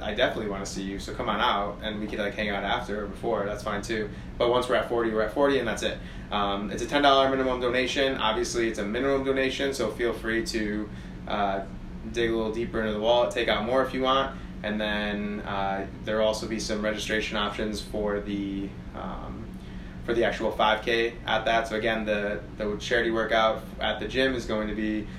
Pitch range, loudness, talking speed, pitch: 105-115 Hz, -27 LUFS, 220 wpm, 110 Hz